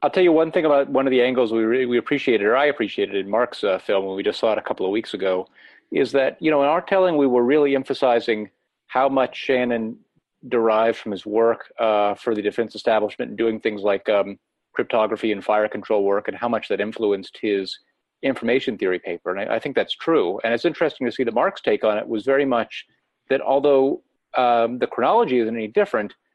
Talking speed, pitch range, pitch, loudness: 230 wpm, 110-140 Hz, 120 Hz, -21 LUFS